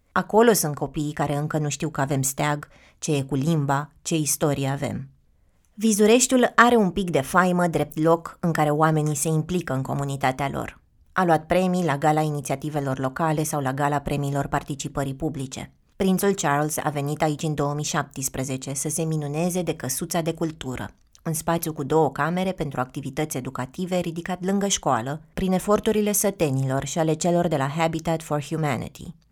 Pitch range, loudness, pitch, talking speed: 140-170 Hz, -24 LUFS, 155 Hz, 170 wpm